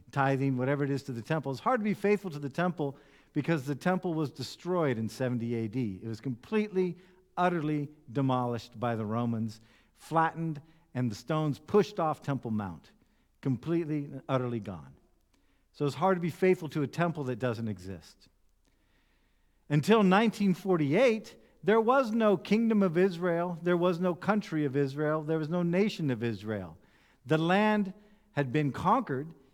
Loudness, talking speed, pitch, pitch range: -30 LUFS, 160 wpm, 150 Hz, 130-180 Hz